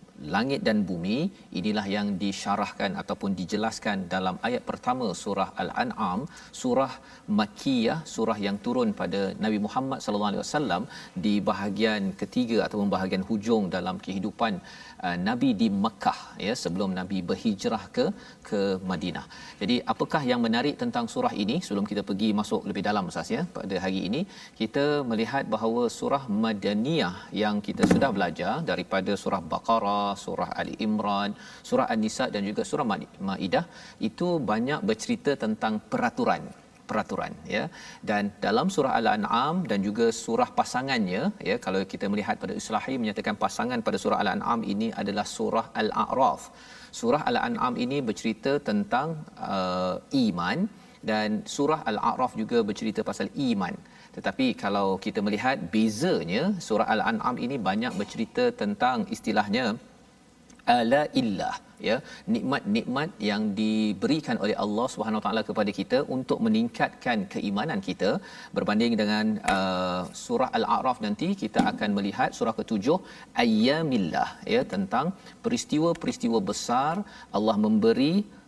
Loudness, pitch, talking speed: -27 LUFS, 205 Hz, 130 wpm